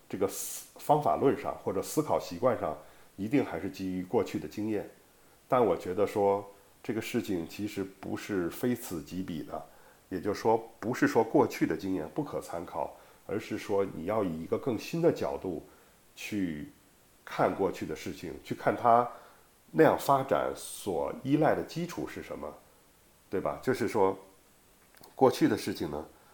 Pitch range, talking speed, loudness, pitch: 95-115 Hz, 240 characters per minute, -31 LUFS, 100 Hz